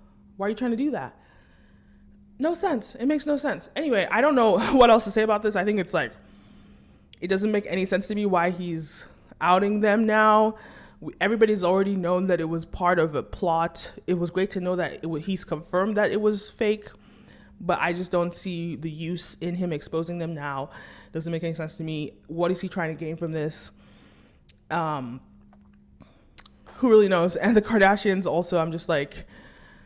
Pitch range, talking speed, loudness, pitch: 165-210 Hz, 200 wpm, -24 LUFS, 180 Hz